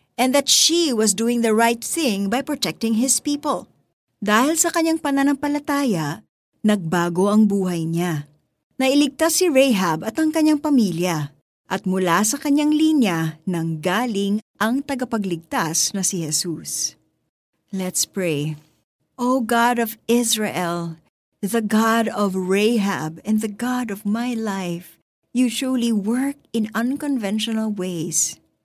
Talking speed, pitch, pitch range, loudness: 130 wpm, 220 Hz, 180-260 Hz, -20 LUFS